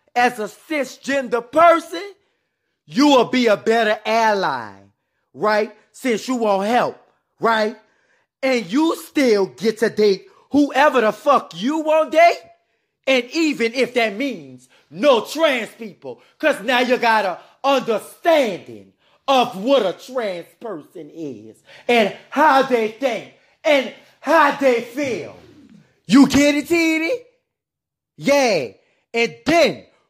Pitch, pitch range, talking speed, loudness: 250 Hz, 215-290 Hz, 130 wpm, -18 LUFS